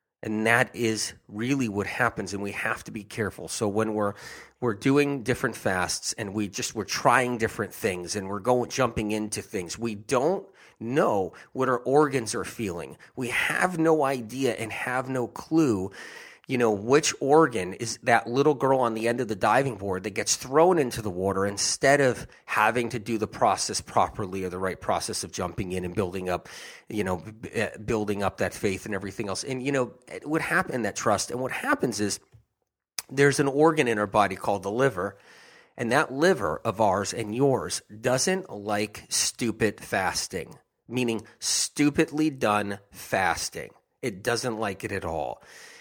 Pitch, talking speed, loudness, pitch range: 115 Hz, 180 wpm, -26 LUFS, 105-130 Hz